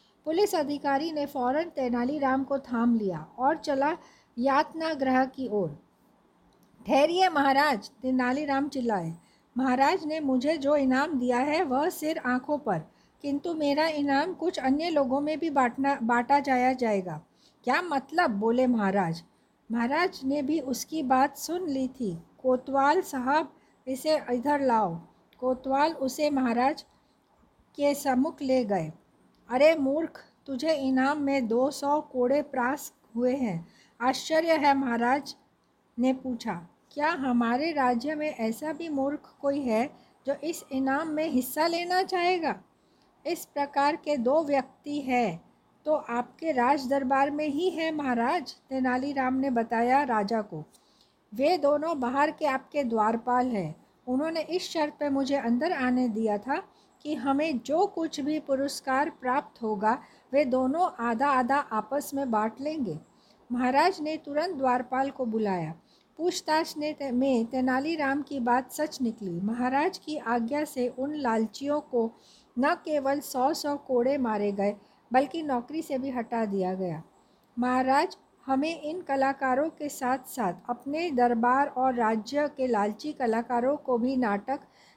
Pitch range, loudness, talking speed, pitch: 245-295 Hz, -28 LUFS, 140 wpm, 270 Hz